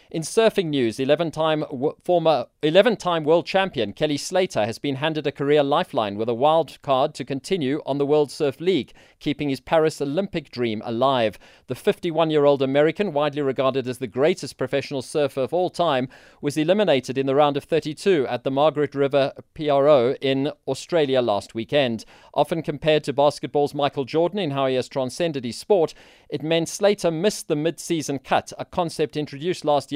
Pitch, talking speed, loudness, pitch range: 145 Hz, 175 wpm, -22 LUFS, 135-165 Hz